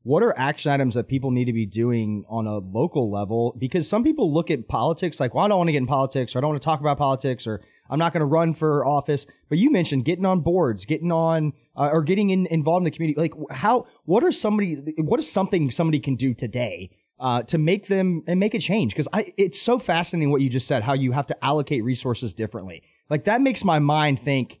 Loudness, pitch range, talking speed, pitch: -22 LUFS, 130-175 Hz, 250 wpm, 150 Hz